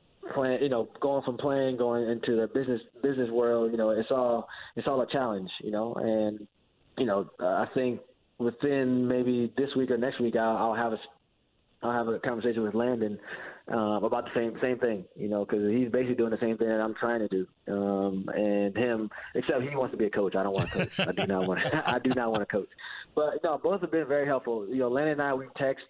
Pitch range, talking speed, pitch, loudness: 110-130 Hz, 245 wpm, 120 Hz, -29 LUFS